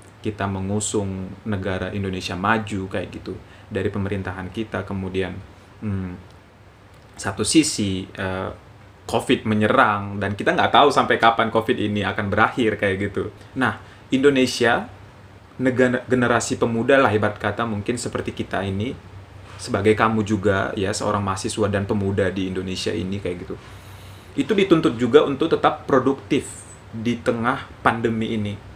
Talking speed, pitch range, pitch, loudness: 135 wpm, 95-115 Hz, 105 Hz, -21 LUFS